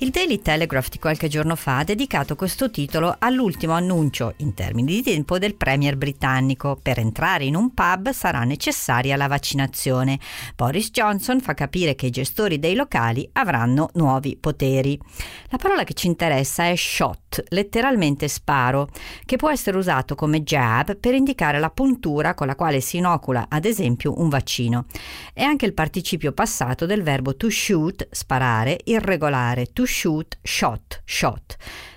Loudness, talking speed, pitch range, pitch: -21 LUFS, 160 wpm, 135-190 Hz, 150 Hz